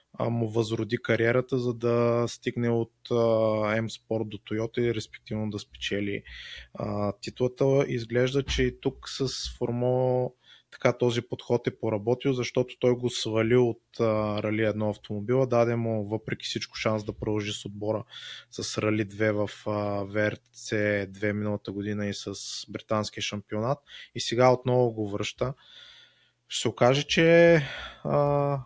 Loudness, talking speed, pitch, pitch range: -27 LUFS, 135 wpm, 115 Hz, 105-125 Hz